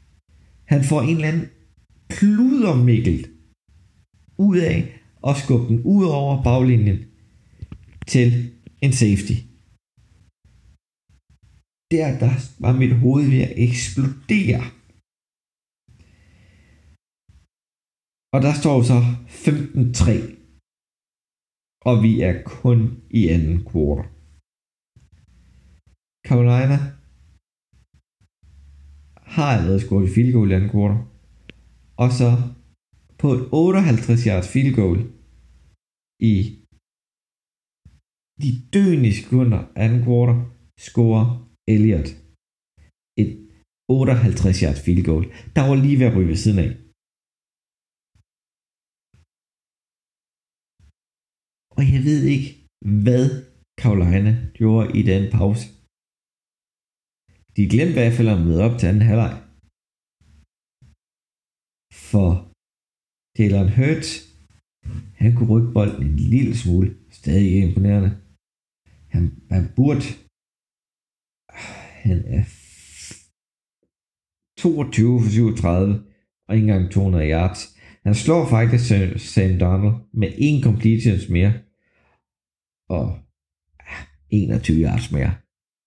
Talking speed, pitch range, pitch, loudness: 95 wpm, 90-125 Hz, 110 Hz, -19 LUFS